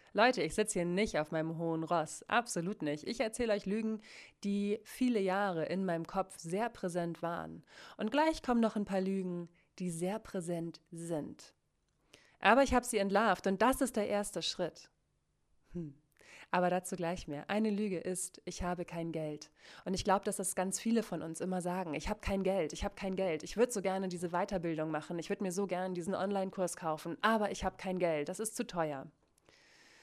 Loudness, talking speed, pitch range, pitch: -35 LUFS, 200 wpm, 170-205 Hz, 185 Hz